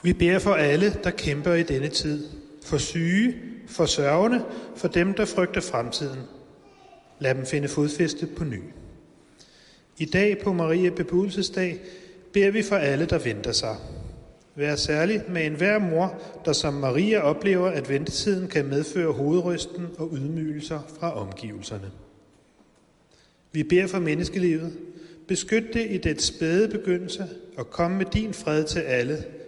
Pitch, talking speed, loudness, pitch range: 170 Hz, 145 wpm, -25 LUFS, 150-185 Hz